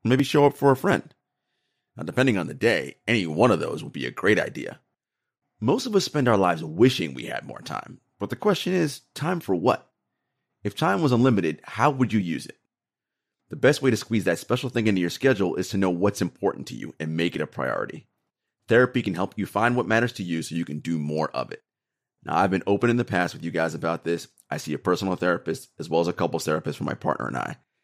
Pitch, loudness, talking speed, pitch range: 95 Hz, -24 LUFS, 245 wpm, 85-125 Hz